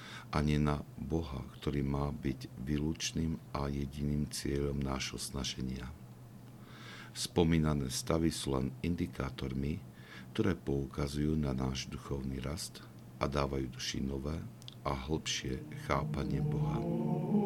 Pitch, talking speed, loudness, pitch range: 70 Hz, 105 wpm, -36 LUFS, 65-75 Hz